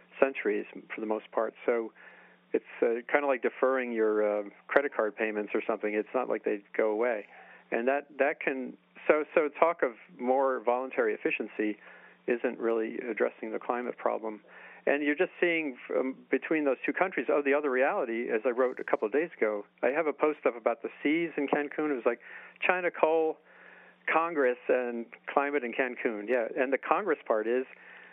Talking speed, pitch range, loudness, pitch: 190 wpm, 110-145 Hz, -30 LUFS, 125 Hz